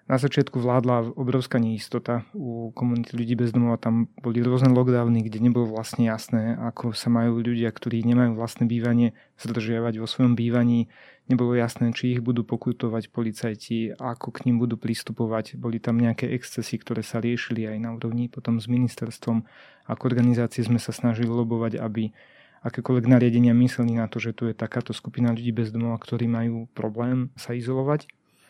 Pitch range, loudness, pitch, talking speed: 115-120 Hz, -25 LUFS, 120 Hz, 170 wpm